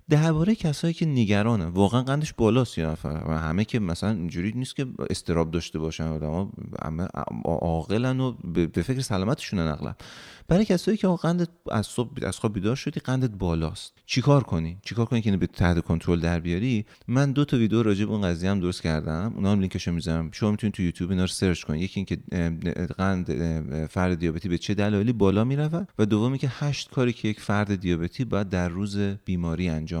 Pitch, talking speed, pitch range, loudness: 100 Hz, 190 wpm, 85-125 Hz, -26 LUFS